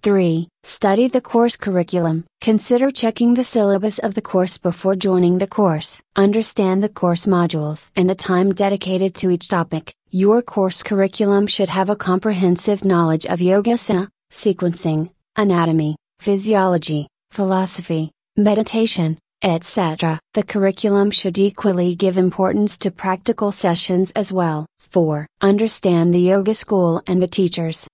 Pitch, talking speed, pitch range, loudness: 190 Hz, 135 wpm, 175-205 Hz, -18 LUFS